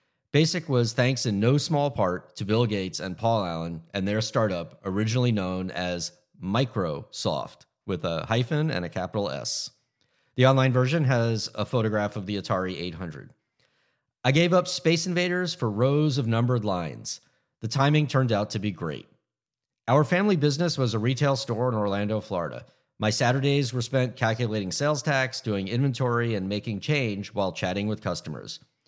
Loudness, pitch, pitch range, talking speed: -26 LUFS, 115 Hz, 100-135 Hz, 165 wpm